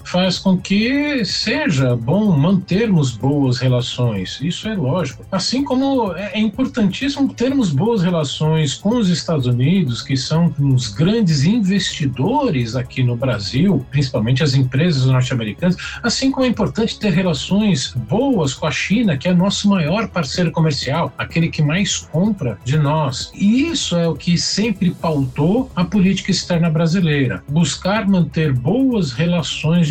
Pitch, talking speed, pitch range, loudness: 170 Hz, 140 wpm, 140-200 Hz, -17 LUFS